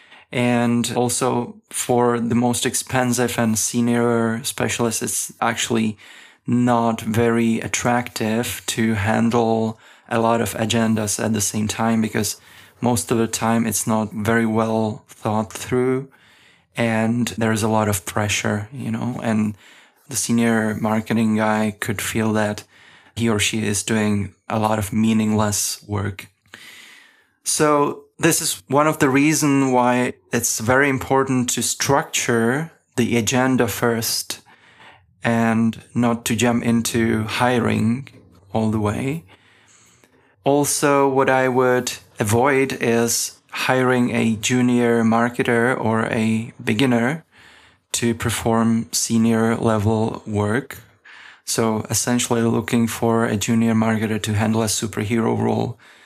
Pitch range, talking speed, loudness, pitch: 110-120 Hz, 125 wpm, -20 LUFS, 115 Hz